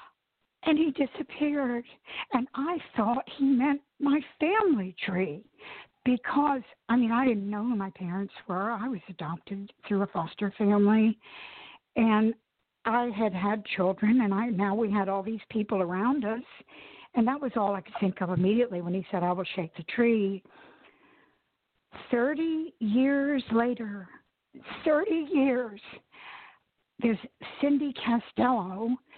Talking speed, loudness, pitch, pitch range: 140 wpm, -28 LUFS, 230 Hz, 200-260 Hz